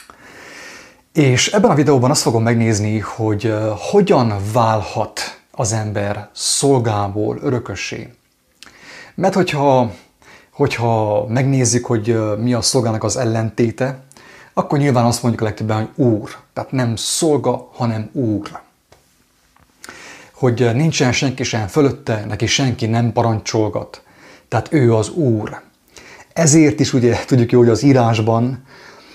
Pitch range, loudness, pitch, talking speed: 110-135 Hz, -16 LUFS, 120 Hz, 120 wpm